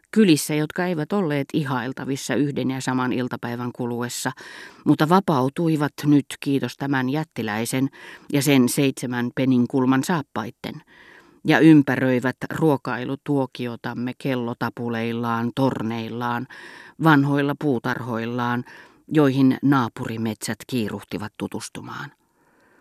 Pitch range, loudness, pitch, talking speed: 120-145 Hz, -22 LUFS, 130 Hz, 85 wpm